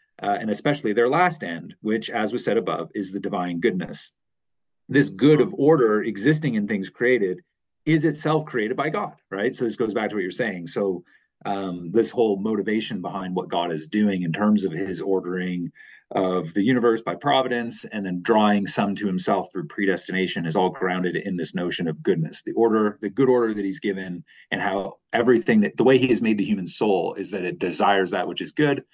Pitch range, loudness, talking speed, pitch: 95-130 Hz, -23 LUFS, 210 wpm, 105 Hz